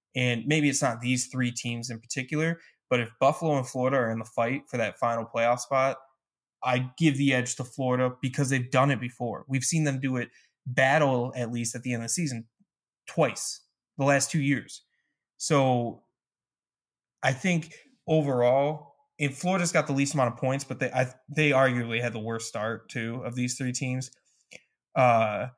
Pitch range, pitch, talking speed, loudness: 120-140 Hz, 130 Hz, 190 wpm, -27 LUFS